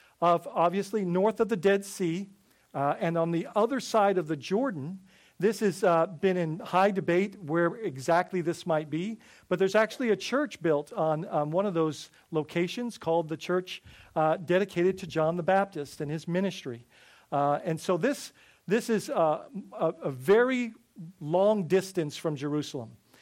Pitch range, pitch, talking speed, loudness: 160-200 Hz, 175 Hz, 170 wpm, -28 LUFS